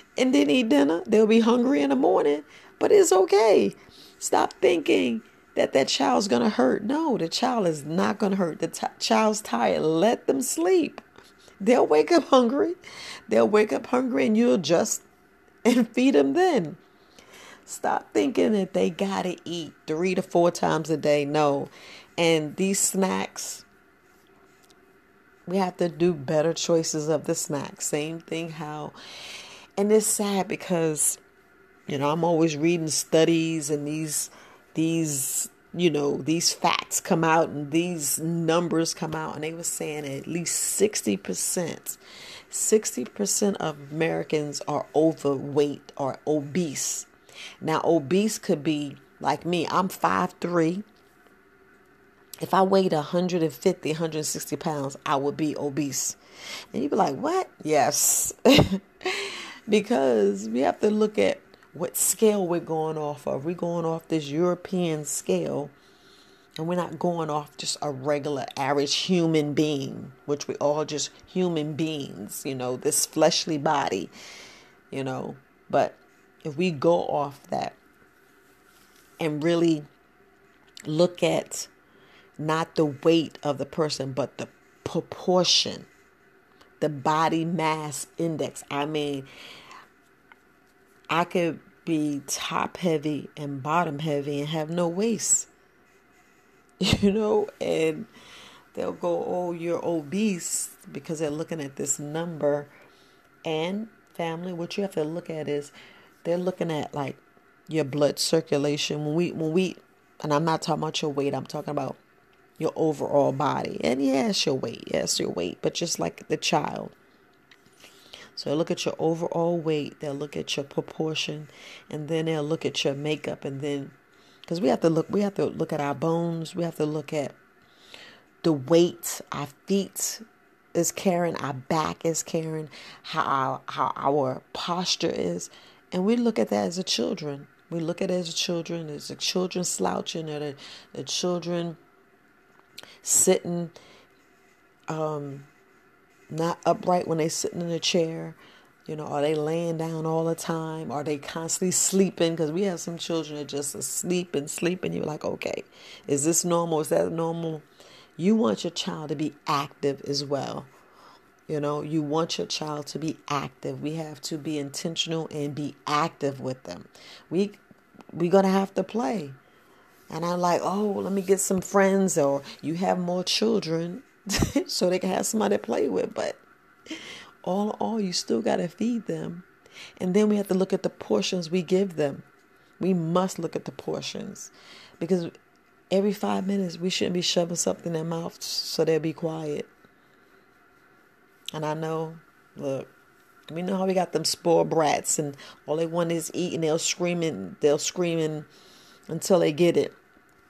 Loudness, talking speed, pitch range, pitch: -26 LUFS, 160 wpm, 150-185 Hz, 165 Hz